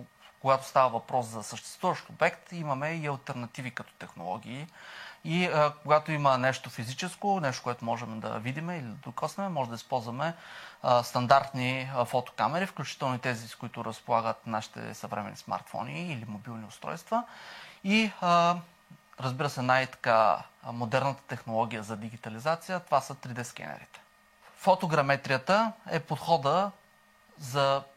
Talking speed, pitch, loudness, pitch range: 135 wpm, 135 Hz, -30 LUFS, 120-165 Hz